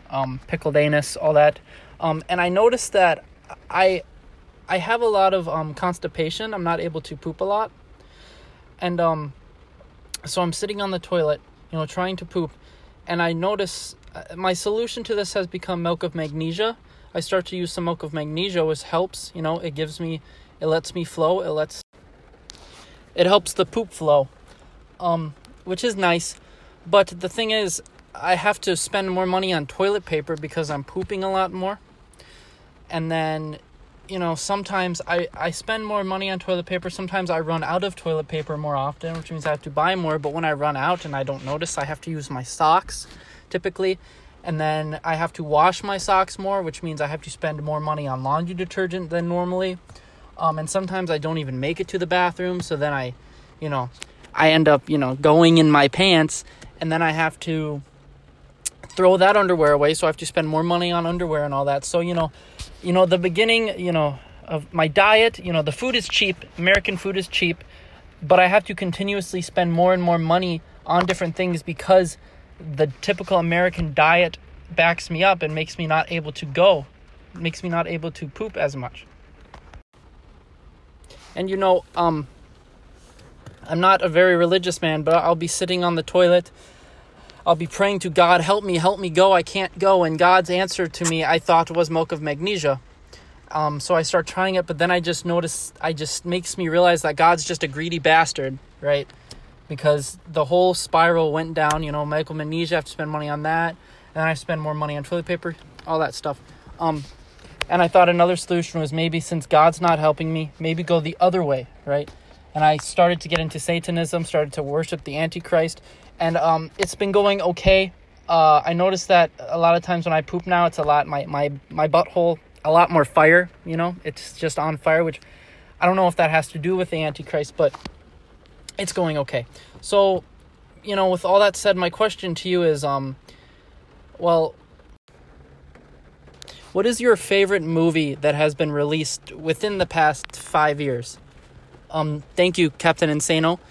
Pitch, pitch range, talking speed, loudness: 165 Hz, 155-180 Hz, 200 wpm, -21 LUFS